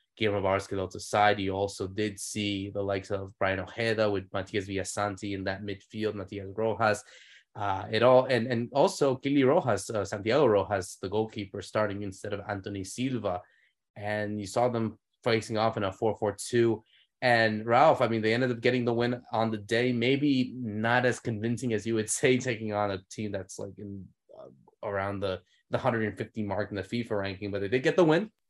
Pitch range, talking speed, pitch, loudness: 100-120 Hz, 195 wpm, 105 Hz, -29 LUFS